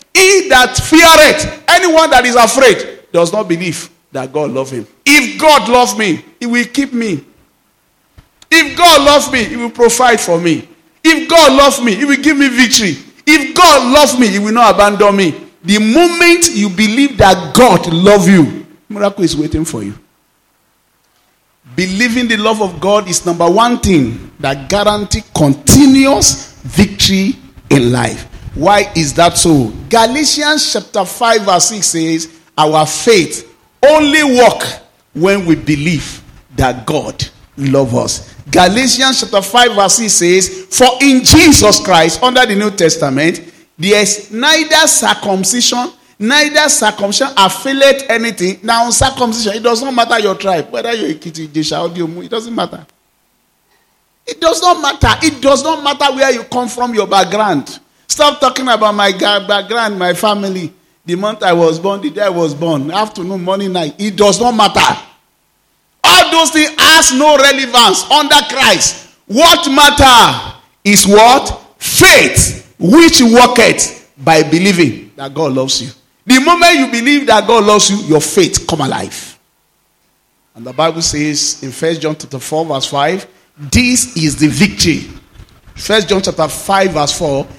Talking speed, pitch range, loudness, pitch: 155 wpm, 170-265 Hz, -9 LUFS, 210 Hz